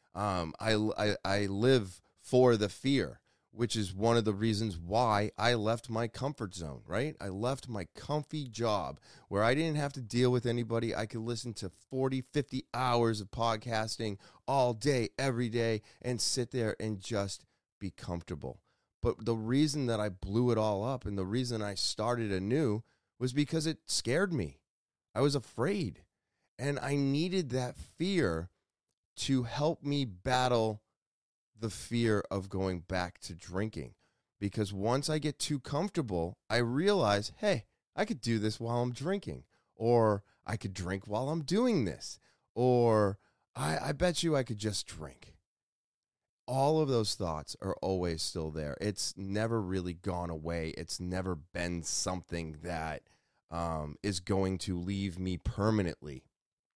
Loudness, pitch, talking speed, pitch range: -33 LUFS, 110 Hz, 160 wpm, 95-125 Hz